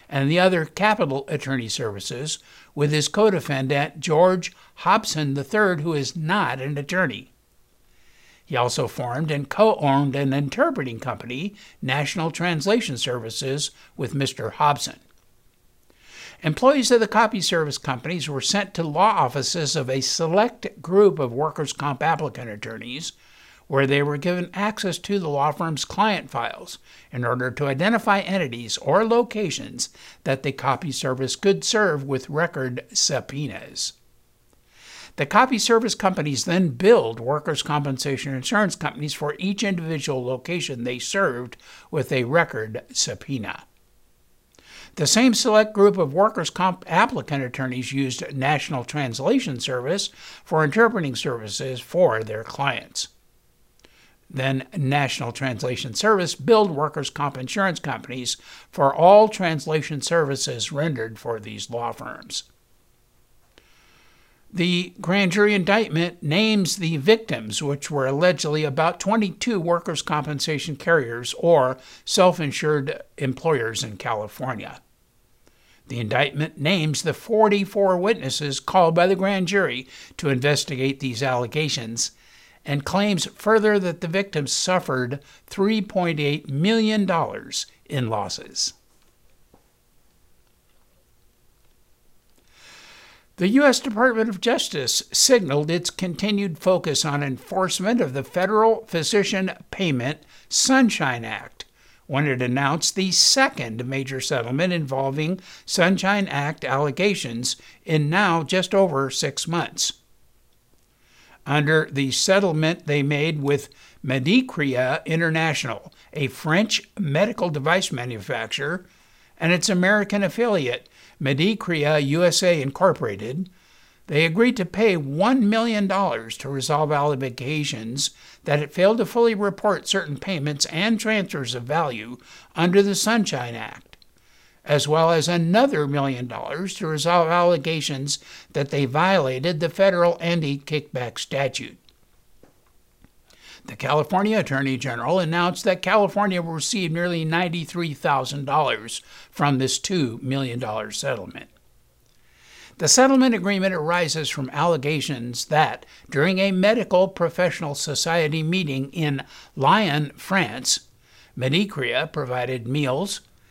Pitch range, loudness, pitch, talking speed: 135-190 Hz, -22 LUFS, 155 Hz, 115 wpm